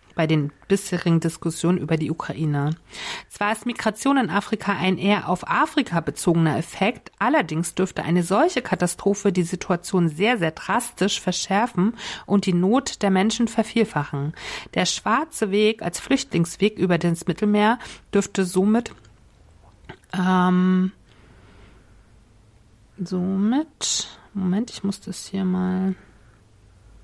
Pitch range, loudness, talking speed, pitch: 165-205 Hz, -22 LUFS, 120 wpm, 185 Hz